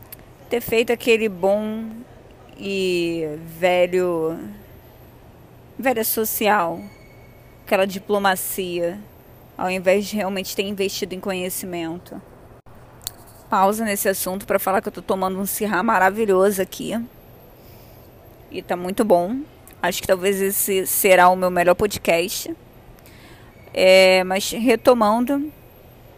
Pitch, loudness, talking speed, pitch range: 190 Hz, -20 LUFS, 110 wpm, 160-205 Hz